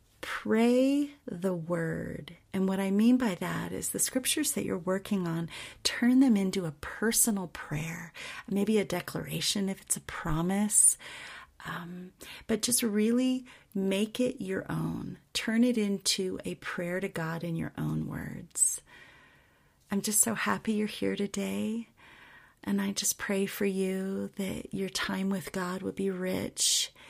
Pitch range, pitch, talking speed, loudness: 185-230 Hz, 200 Hz, 155 wpm, -30 LUFS